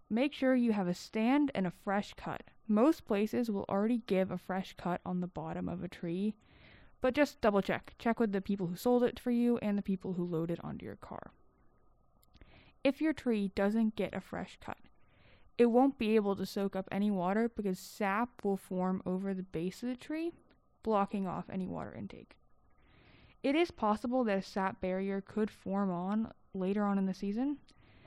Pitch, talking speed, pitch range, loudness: 200 Hz, 195 wpm, 190-235 Hz, -34 LUFS